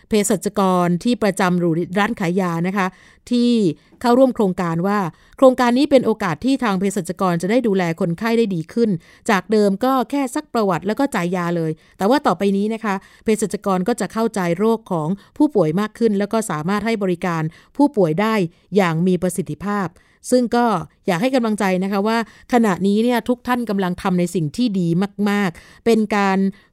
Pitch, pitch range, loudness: 205 Hz, 185-230 Hz, -19 LUFS